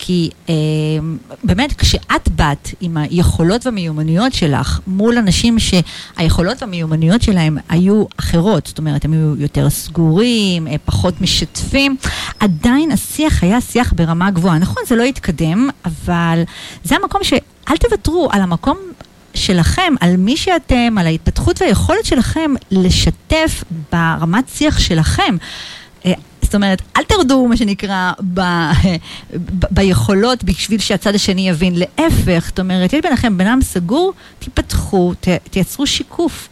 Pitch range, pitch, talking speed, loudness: 170-245 Hz, 190 Hz, 125 wpm, -14 LUFS